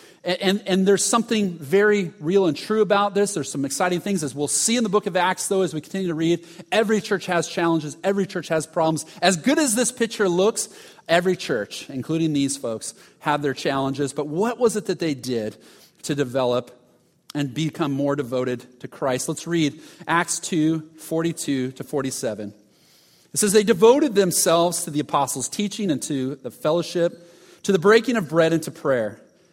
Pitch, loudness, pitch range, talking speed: 170 Hz, -22 LUFS, 145-195 Hz, 190 wpm